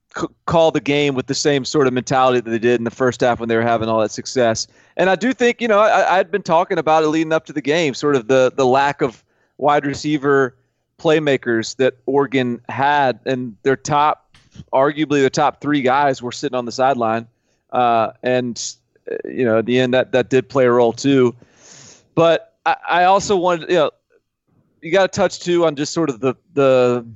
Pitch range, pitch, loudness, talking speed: 125-155 Hz, 135 Hz, -17 LUFS, 215 wpm